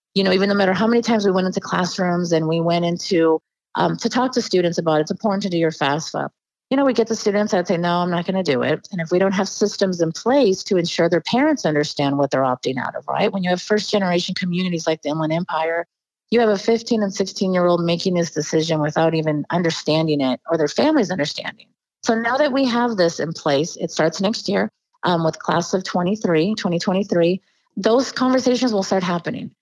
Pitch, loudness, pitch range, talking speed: 180 Hz, -20 LUFS, 165-205 Hz, 235 wpm